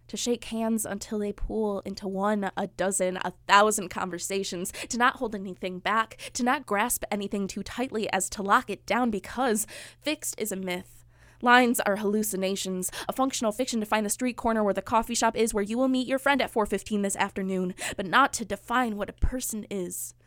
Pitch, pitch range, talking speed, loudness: 205 Hz, 195-235 Hz, 200 wpm, -27 LUFS